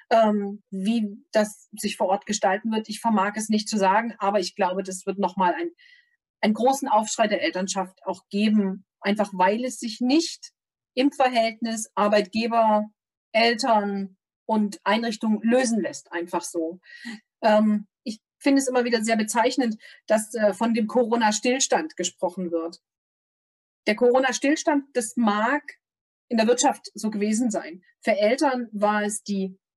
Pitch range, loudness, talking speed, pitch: 200-240 Hz, -24 LUFS, 140 wpm, 215 Hz